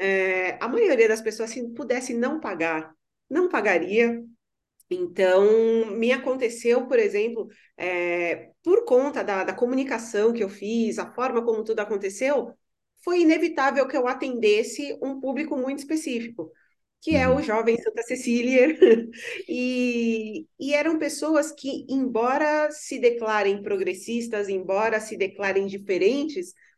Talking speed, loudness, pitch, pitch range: 130 wpm, -24 LUFS, 240 Hz, 215-290 Hz